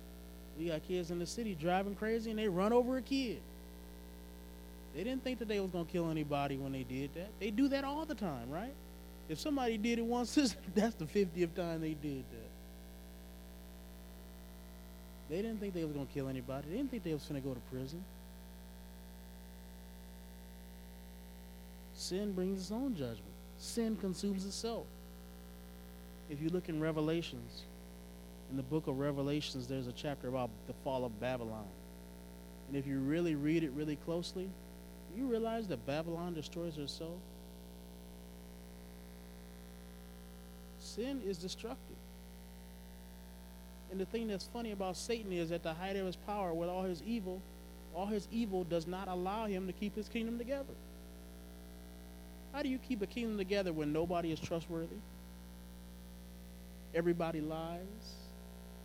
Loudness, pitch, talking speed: -39 LUFS, 135 Hz, 155 wpm